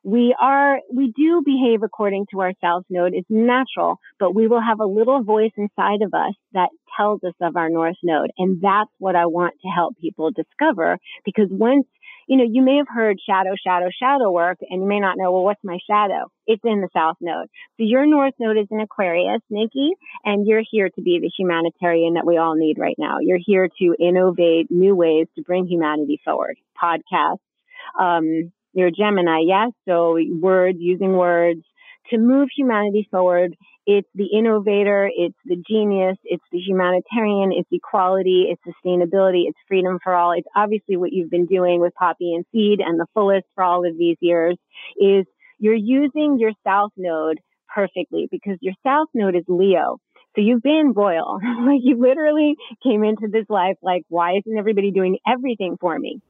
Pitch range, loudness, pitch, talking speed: 175-225 Hz, -19 LUFS, 195 Hz, 190 wpm